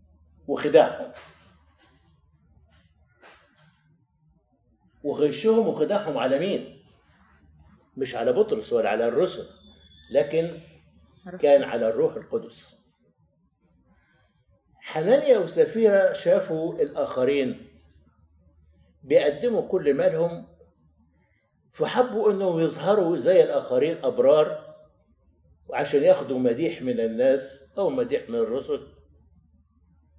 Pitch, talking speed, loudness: 140 Hz, 75 wpm, -23 LUFS